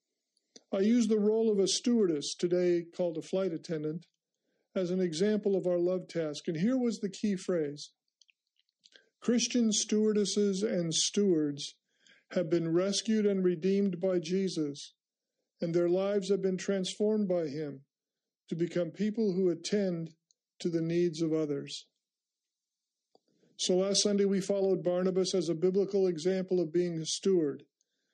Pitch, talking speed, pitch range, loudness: 185 Hz, 145 wpm, 170-200 Hz, -31 LUFS